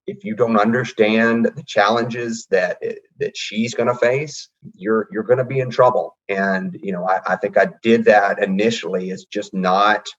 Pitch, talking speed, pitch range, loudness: 115 Hz, 195 wpm, 105-125 Hz, -18 LUFS